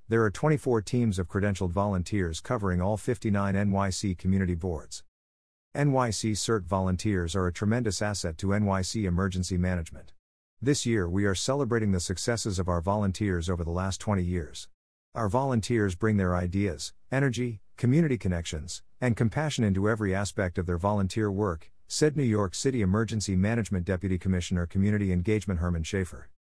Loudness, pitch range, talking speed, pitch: -28 LUFS, 90-110 Hz, 155 wpm, 100 Hz